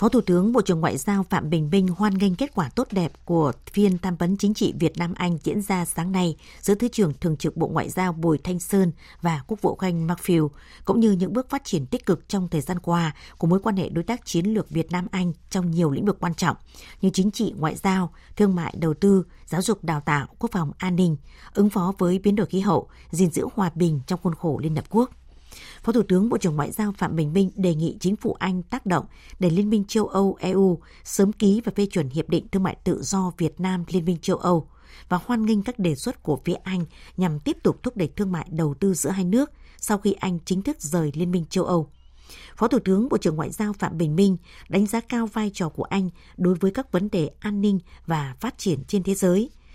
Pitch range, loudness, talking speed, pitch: 170-205 Hz, -24 LUFS, 250 wpm, 185 Hz